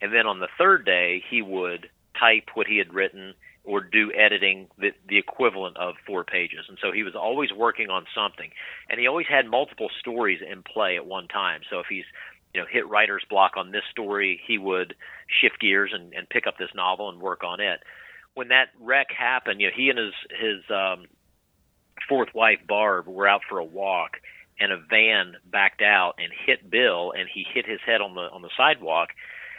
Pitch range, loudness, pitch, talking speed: 90-100 Hz, -23 LUFS, 95 Hz, 210 wpm